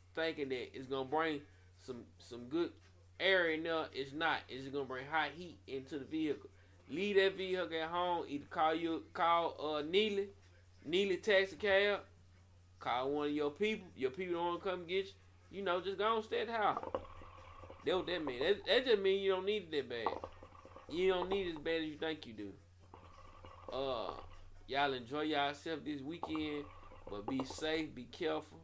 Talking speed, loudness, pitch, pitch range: 200 wpm, -37 LUFS, 155 Hz, 125-190 Hz